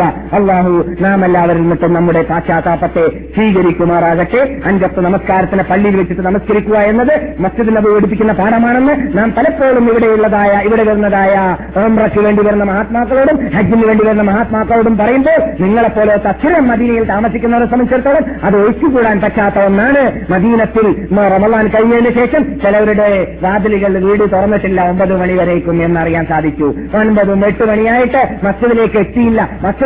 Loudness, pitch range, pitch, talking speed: -11 LUFS, 190-230 Hz, 210 Hz, 115 wpm